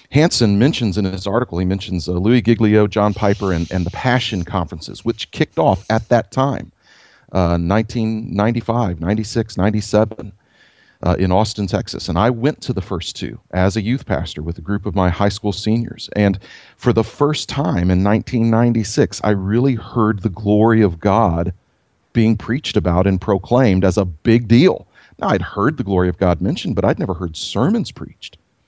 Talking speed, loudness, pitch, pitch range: 180 wpm, -17 LUFS, 105 Hz, 95-115 Hz